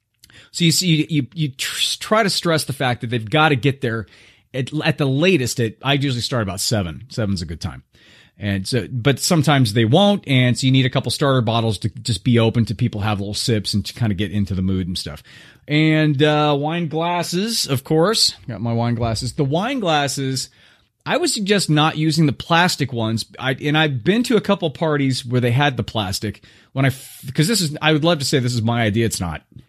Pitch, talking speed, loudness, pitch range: 130 Hz, 230 wpm, -19 LUFS, 115-155 Hz